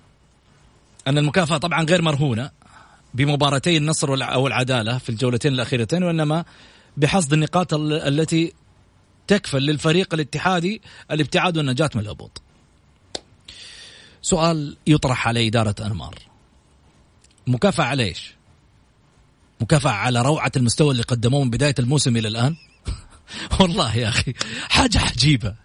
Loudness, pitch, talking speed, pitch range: -20 LUFS, 140 Hz, 110 wpm, 115-155 Hz